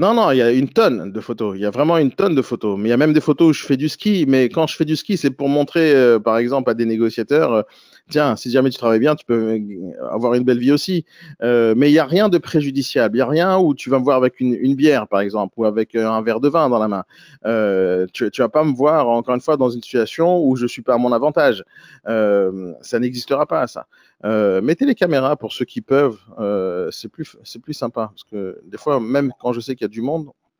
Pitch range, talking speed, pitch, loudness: 115-150 Hz, 280 wpm, 125 Hz, -17 LUFS